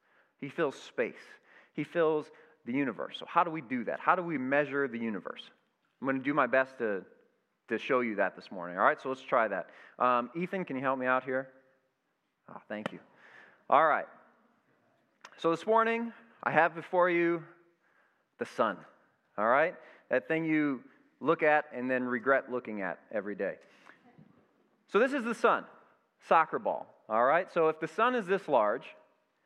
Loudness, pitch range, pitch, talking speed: -31 LUFS, 130-175 Hz, 150 Hz, 185 wpm